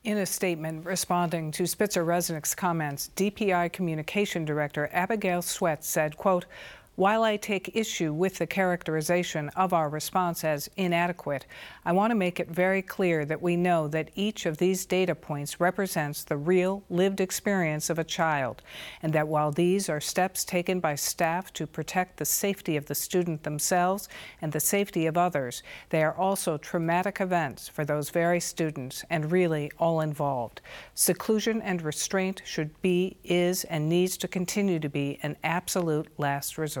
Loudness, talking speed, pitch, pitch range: -28 LUFS, 165 wpm, 175 Hz, 155-185 Hz